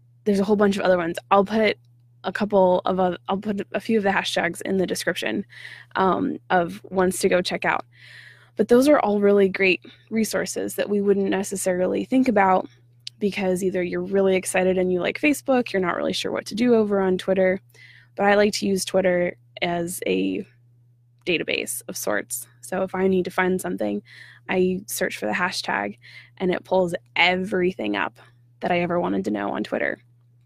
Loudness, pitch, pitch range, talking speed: -22 LUFS, 185 Hz, 125-195 Hz, 195 wpm